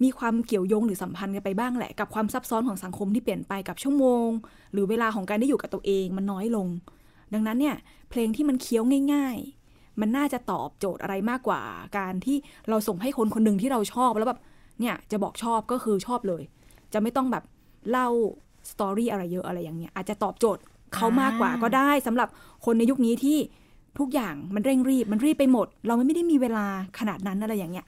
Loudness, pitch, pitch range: -26 LUFS, 225 Hz, 200-250 Hz